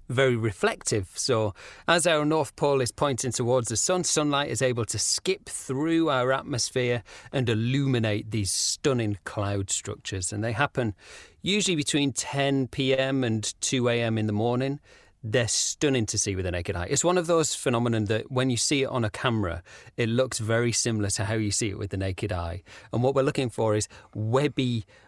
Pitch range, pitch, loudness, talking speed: 105-135 Hz, 120 Hz, -26 LUFS, 190 wpm